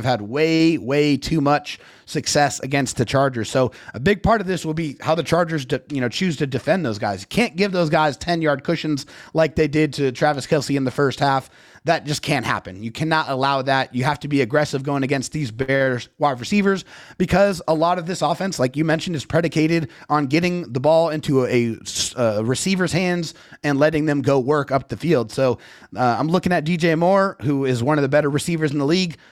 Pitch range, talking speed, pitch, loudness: 135-165 Hz, 225 wpm, 150 Hz, -20 LUFS